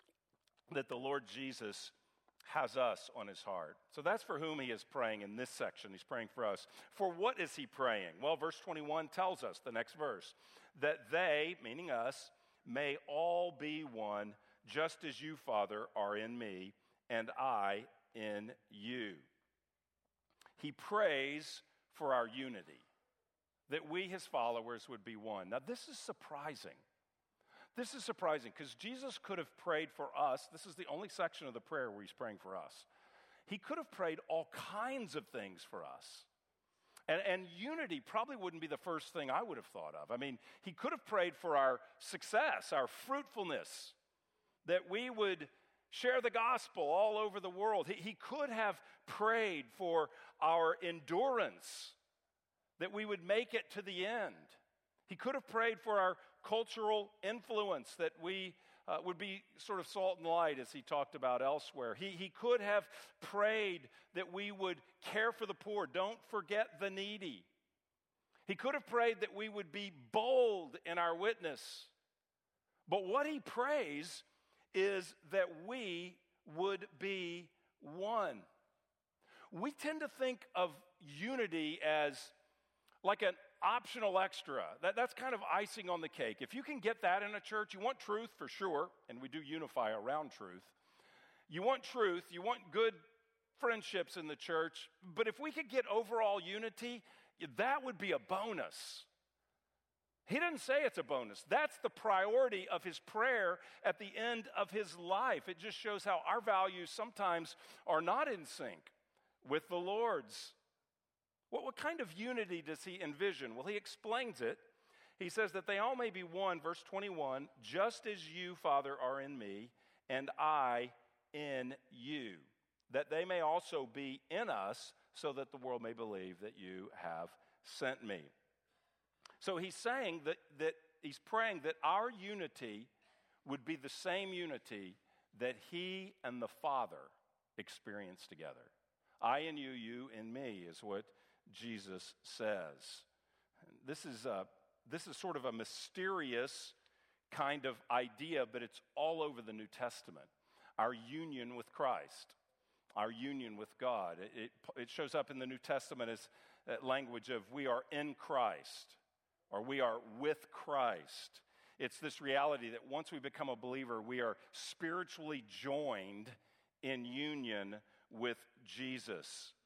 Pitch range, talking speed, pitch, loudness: 135-215 Hz, 160 wpm, 175 Hz, -41 LUFS